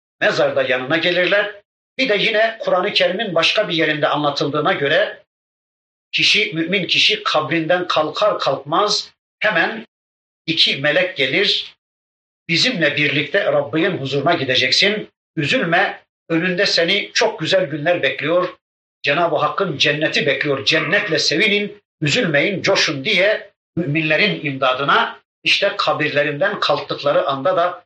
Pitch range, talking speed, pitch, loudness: 150-195 Hz, 110 wpm, 165 Hz, -17 LUFS